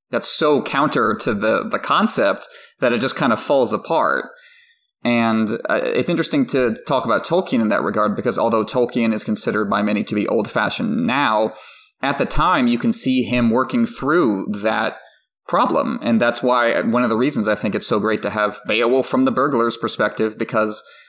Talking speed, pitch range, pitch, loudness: 195 wpm, 110-125 Hz, 115 Hz, -19 LUFS